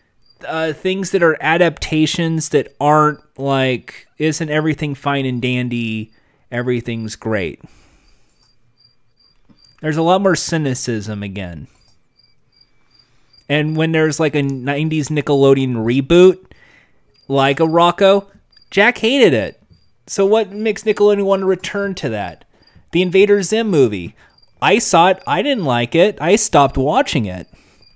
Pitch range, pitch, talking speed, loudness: 125-185 Hz, 150 Hz, 125 wpm, -16 LUFS